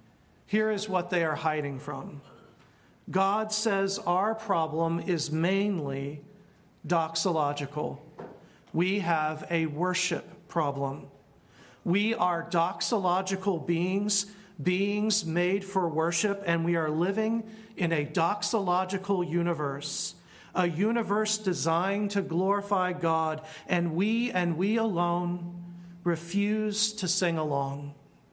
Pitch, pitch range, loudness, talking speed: 180 Hz, 165-200 Hz, -28 LUFS, 105 wpm